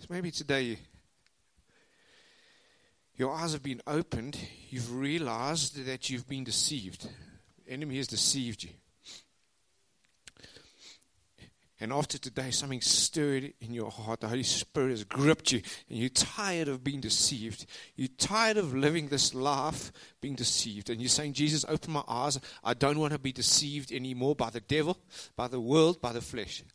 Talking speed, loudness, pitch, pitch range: 155 wpm, -31 LUFS, 130 Hz, 120-150 Hz